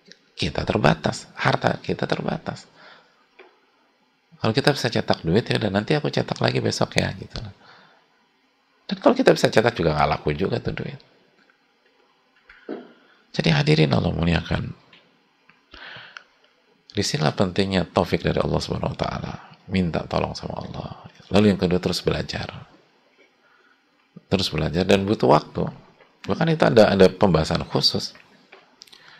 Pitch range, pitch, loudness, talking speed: 90-120 Hz, 100 Hz, -22 LUFS, 125 wpm